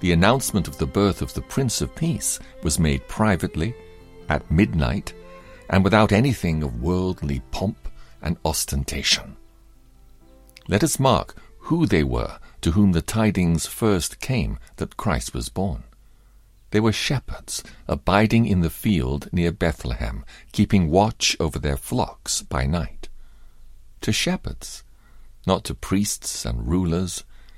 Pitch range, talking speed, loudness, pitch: 75-100 Hz, 135 wpm, -23 LUFS, 85 Hz